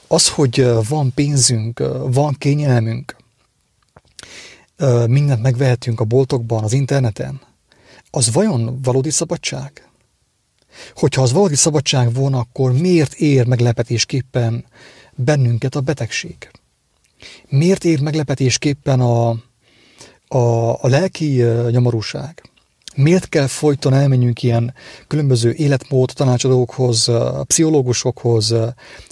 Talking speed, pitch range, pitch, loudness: 95 wpm, 120-145 Hz, 130 Hz, -16 LUFS